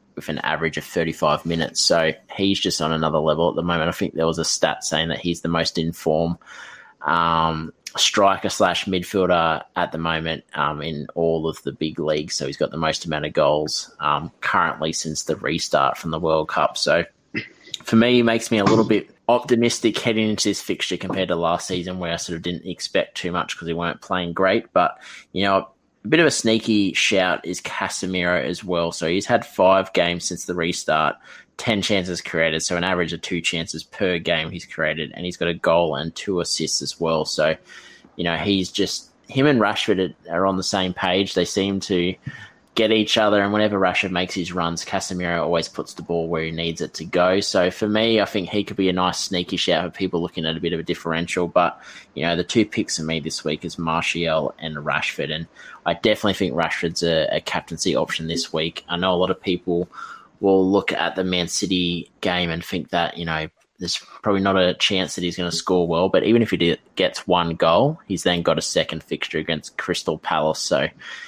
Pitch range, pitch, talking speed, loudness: 80-95 Hz, 90 Hz, 220 wpm, -21 LUFS